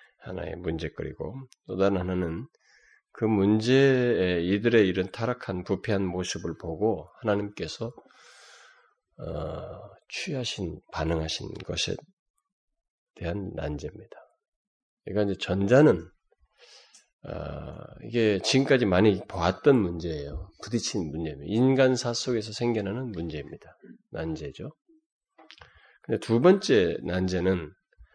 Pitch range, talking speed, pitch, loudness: 90-130 Hz, 245 characters per minute, 105 Hz, -27 LUFS